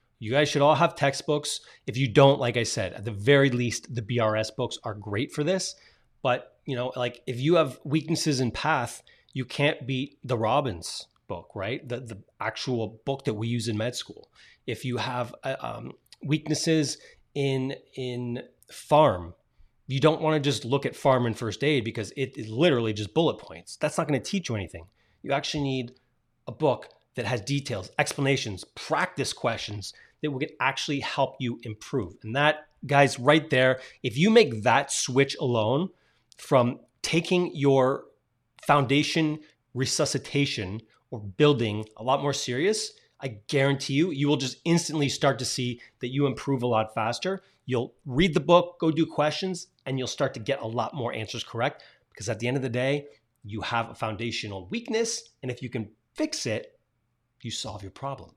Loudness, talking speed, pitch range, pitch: -27 LUFS, 185 wpm, 115-150 Hz, 130 Hz